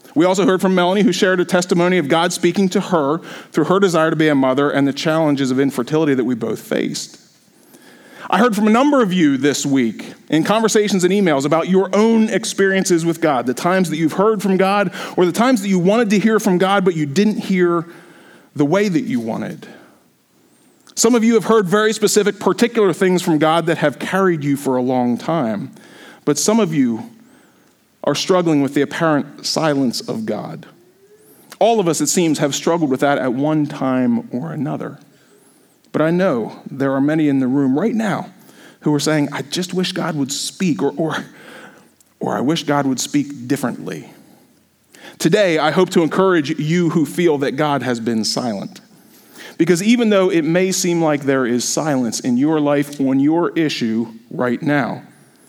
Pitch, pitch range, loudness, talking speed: 170 Hz, 145-195 Hz, -17 LUFS, 195 wpm